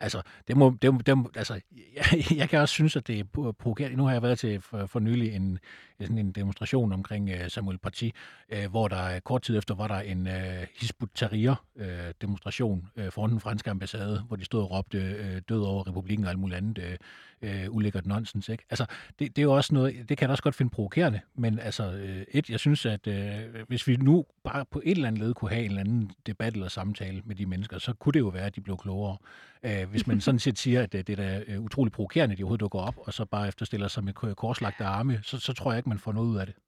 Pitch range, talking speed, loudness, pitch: 100-125 Hz, 240 wpm, -29 LUFS, 110 Hz